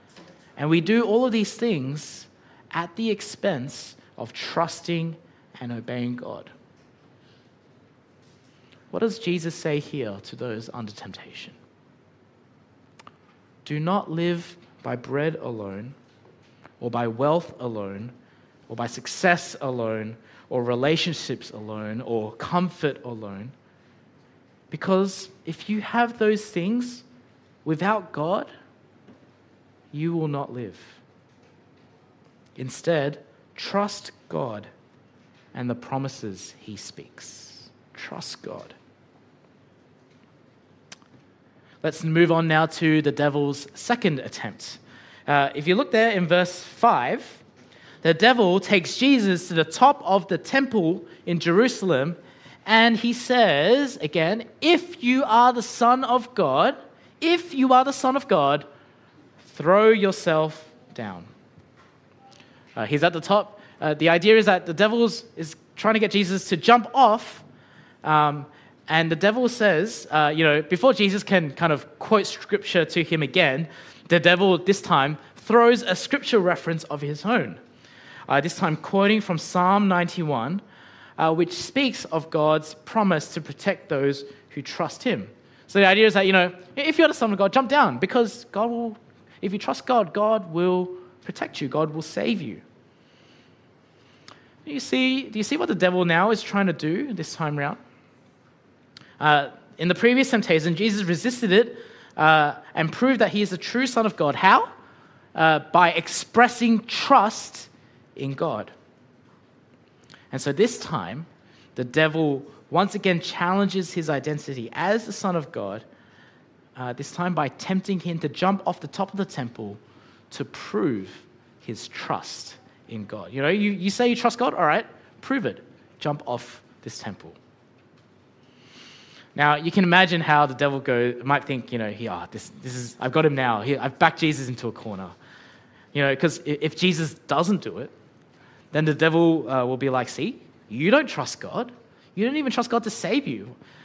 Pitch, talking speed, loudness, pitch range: 170 Hz, 150 wpm, -22 LUFS, 140-205 Hz